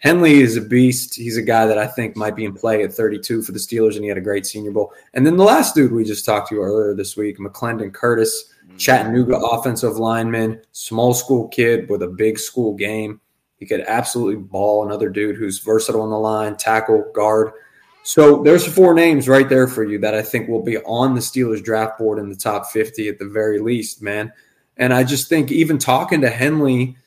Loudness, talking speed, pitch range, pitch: -17 LUFS, 220 wpm, 105-125 Hz, 110 Hz